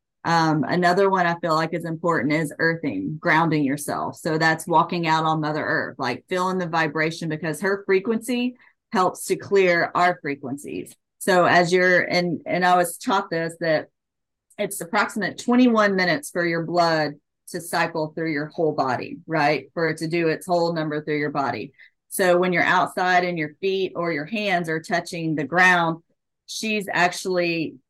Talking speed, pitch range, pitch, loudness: 175 wpm, 160-180 Hz, 170 Hz, -22 LUFS